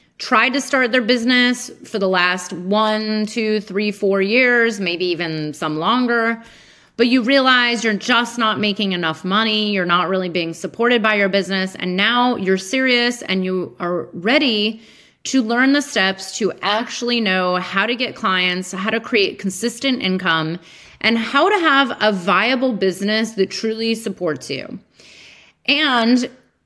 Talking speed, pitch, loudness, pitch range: 160 wpm, 215 Hz, -17 LUFS, 190-240 Hz